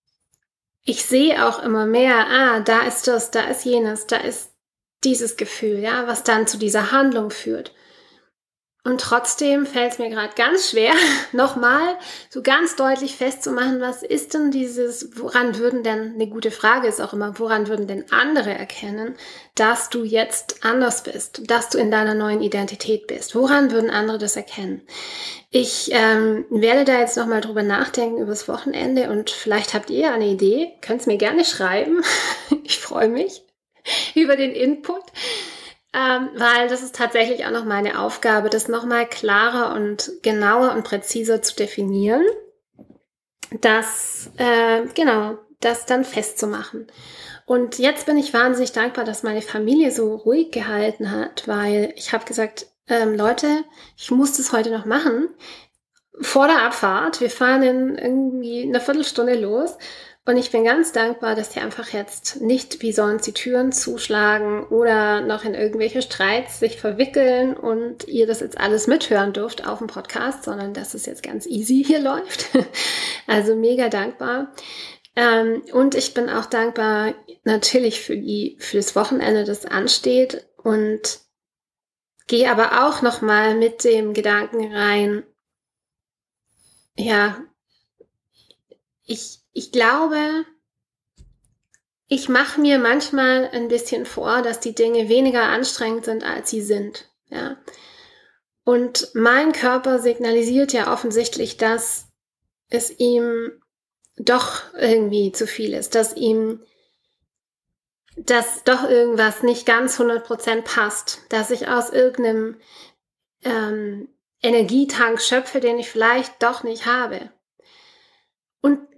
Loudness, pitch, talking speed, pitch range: -19 LUFS, 235 Hz, 140 wpm, 220-255 Hz